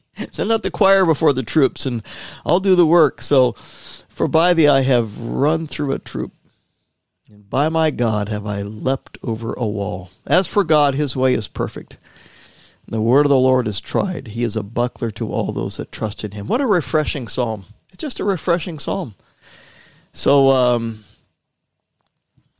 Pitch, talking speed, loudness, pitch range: 130 Hz, 180 wpm, -19 LUFS, 110-160 Hz